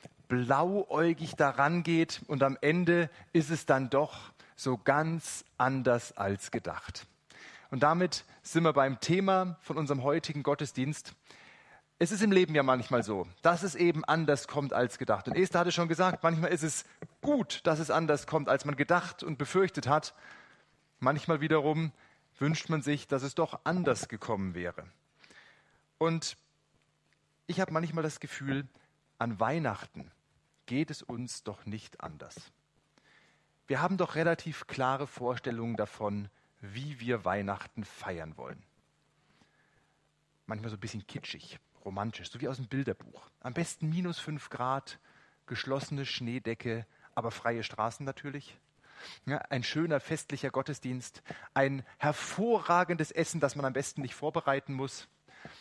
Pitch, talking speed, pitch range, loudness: 145 Hz, 140 wpm, 125-160 Hz, -32 LUFS